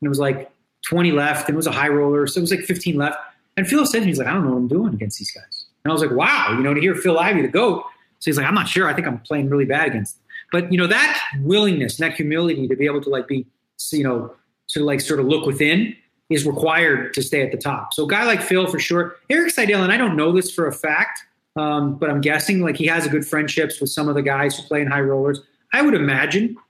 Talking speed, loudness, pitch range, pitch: 290 wpm, -19 LUFS, 145-185 Hz, 155 Hz